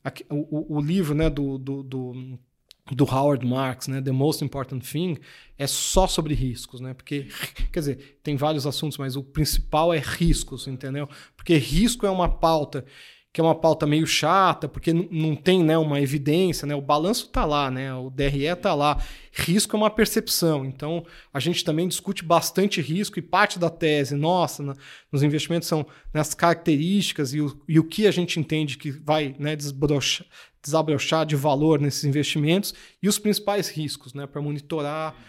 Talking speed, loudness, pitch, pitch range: 180 wpm, -24 LUFS, 150 Hz, 140-170 Hz